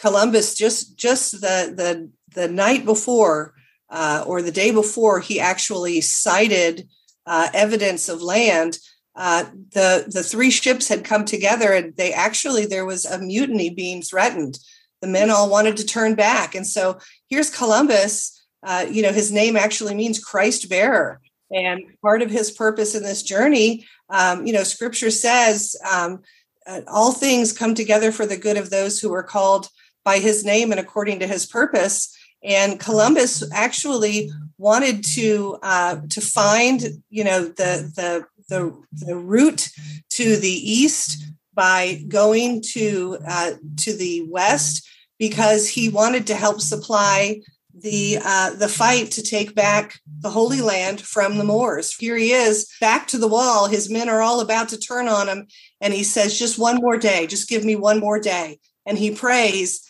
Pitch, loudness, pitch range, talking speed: 210 Hz, -19 LUFS, 185-220 Hz, 170 wpm